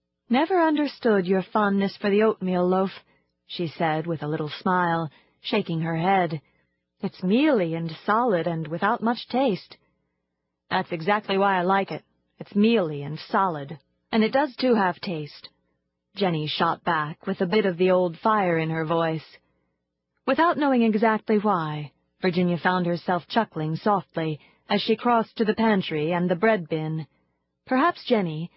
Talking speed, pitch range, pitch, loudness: 160 wpm, 155-215 Hz, 180 Hz, -24 LUFS